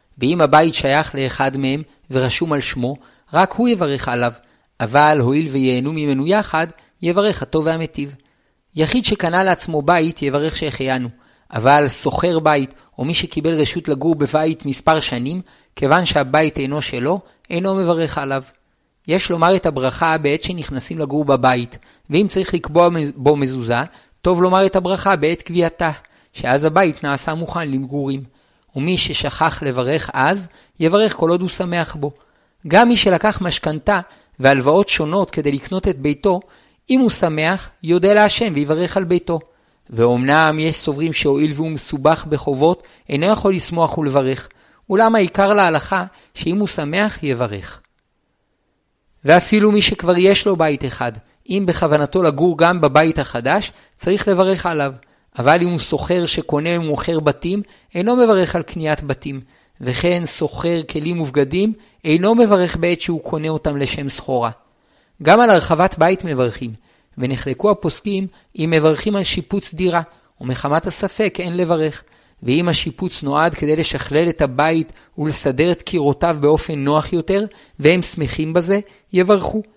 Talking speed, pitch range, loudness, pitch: 140 wpm, 145-180 Hz, -17 LUFS, 160 Hz